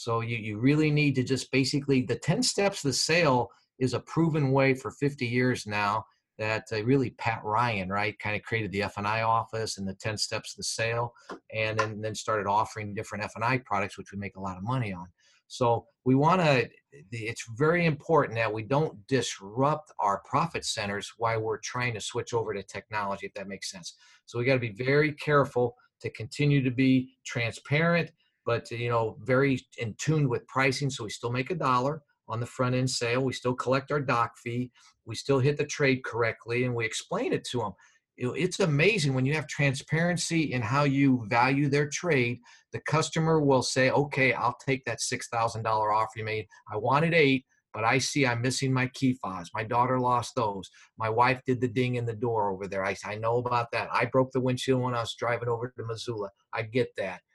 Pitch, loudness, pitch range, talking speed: 125 Hz, -28 LUFS, 115-135 Hz, 210 wpm